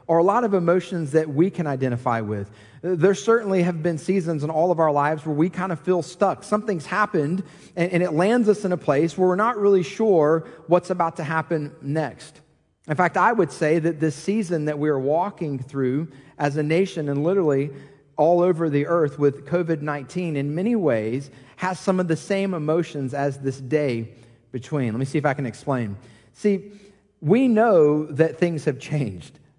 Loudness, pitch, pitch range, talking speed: -22 LUFS, 160 Hz, 145-180 Hz, 195 wpm